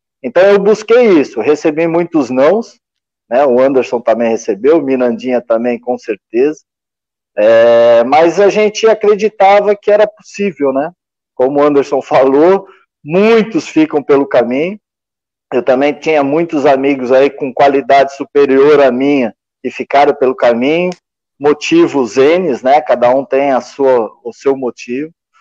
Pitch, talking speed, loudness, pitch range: 140 Hz, 140 wpm, -11 LUFS, 130-170 Hz